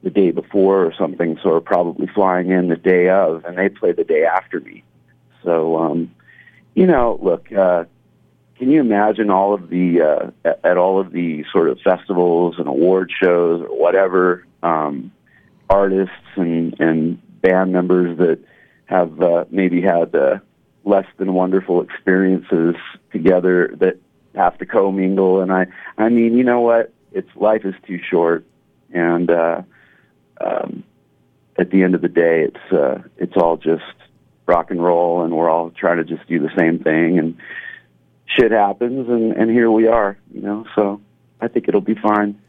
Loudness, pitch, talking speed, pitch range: -17 LUFS, 90 Hz, 170 wpm, 85-100 Hz